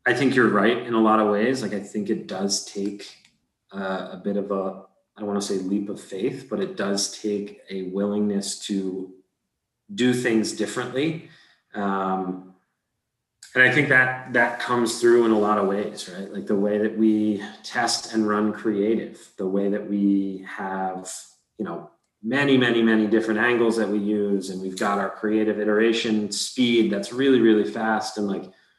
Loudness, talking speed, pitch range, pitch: -23 LUFS, 185 wpm, 100-115 Hz, 105 Hz